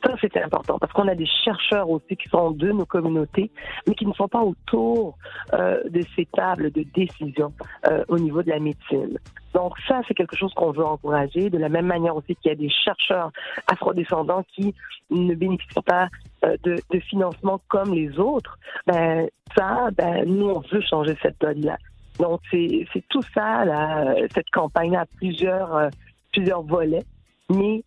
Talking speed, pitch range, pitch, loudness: 185 wpm, 160-195 Hz, 175 Hz, -23 LUFS